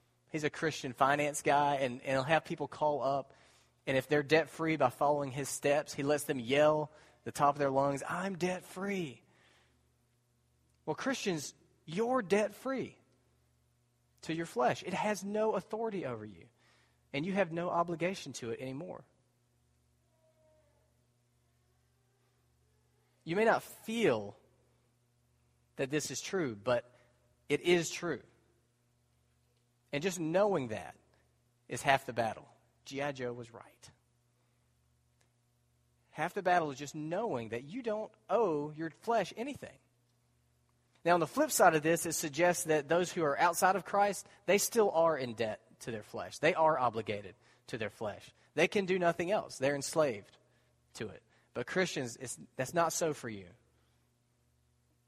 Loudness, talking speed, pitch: -33 LUFS, 150 wpm, 135 Hz